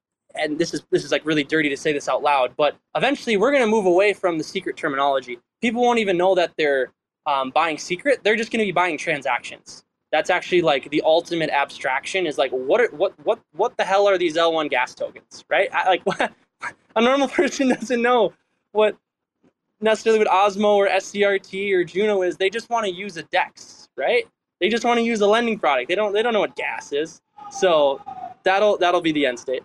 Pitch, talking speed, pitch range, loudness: 200 Hz, 220 wpm, 165-235 Hz, -21 LUFS